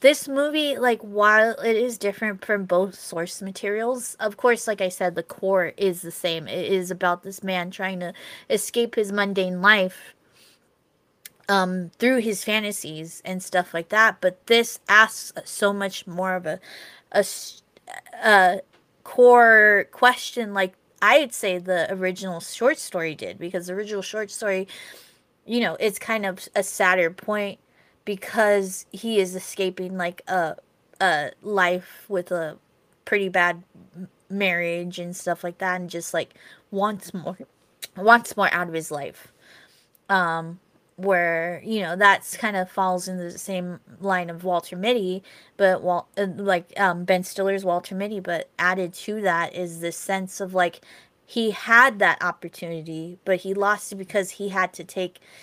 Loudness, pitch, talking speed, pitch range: -22 LUFS, 190 Hz, 160 wpm, 180-210 Hz